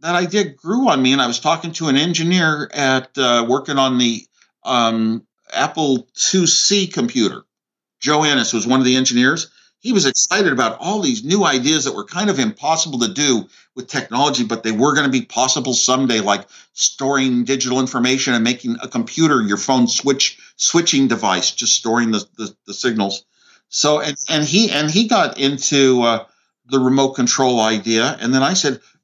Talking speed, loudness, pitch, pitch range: 185 wpm, -16 LUFS, 135 Hz, 120-160 Hz